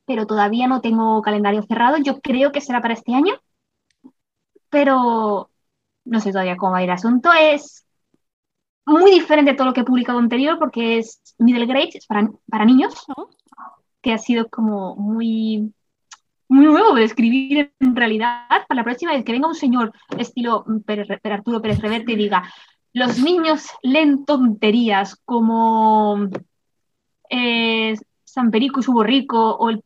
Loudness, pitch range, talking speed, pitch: -17 LUFS, 220-270 Hz, 165 wpm, 235 Hz